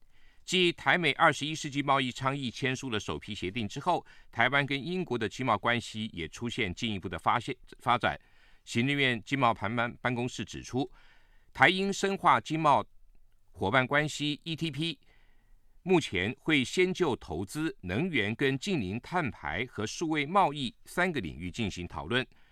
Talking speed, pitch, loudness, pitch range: 250 characters per minute, 130 Hz, -30 LUFS, 105-155 Hz